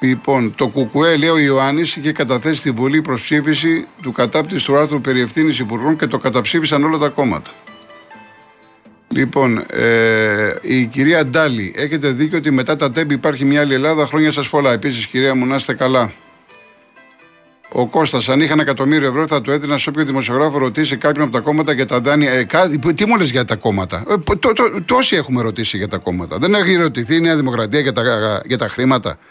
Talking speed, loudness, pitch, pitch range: 200 wpm, -15 LUFS, 140 Hz, 125-155 Hz